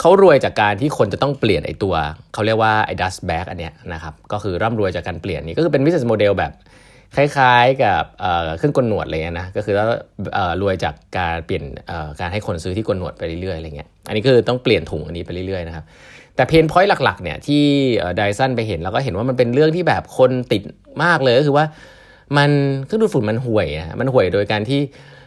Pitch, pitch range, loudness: 110 Hz, 90-140 Hz, -18 LUFS